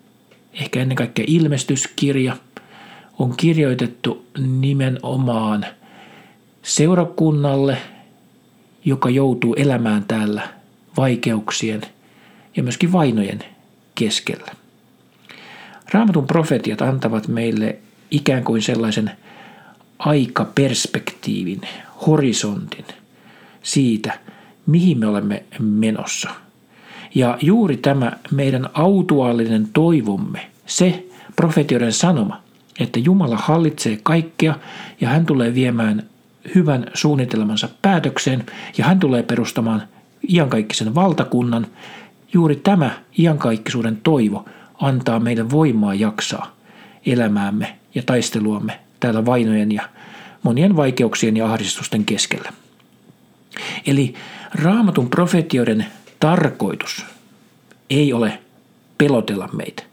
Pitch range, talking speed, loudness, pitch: 115-170 Hz, 85 wpm, -18 LUFS, 135 Hz